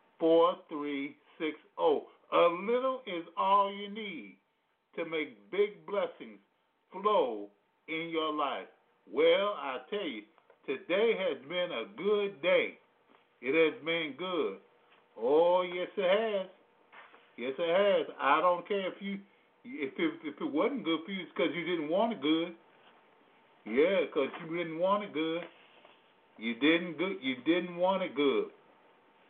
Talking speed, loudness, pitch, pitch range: 145 wpm, -32 LUFS, 185 Hz, 165-250 Hz